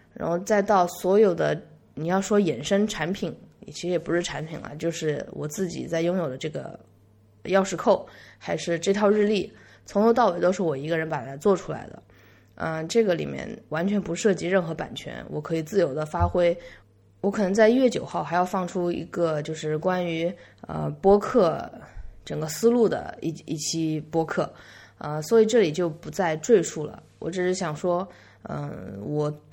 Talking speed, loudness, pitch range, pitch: 265 characters per minute, -25 LUFS, 150-195 Hz, 170 Hz